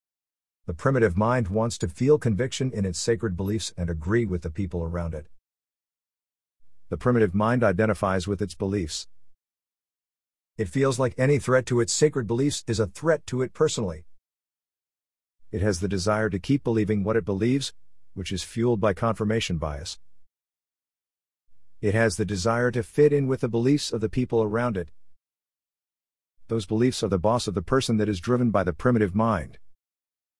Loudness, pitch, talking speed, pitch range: -25 LUFS, 110 Hz, 170 wpm, 90-120 Hz